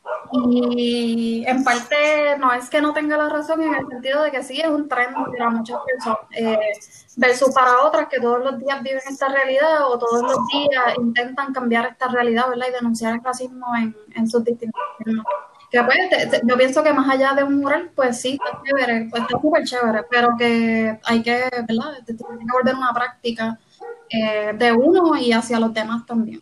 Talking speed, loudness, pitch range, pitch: 200 wpm, -19 LUFS, 235-275 Hz, 250 Hz